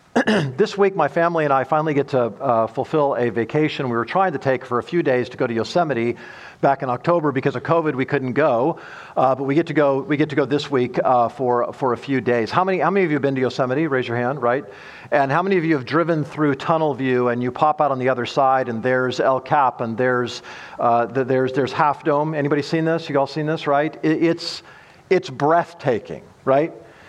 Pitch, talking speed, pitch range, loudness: 140 Hz, 245 wpm, 125-160 Hz, -20 LUFS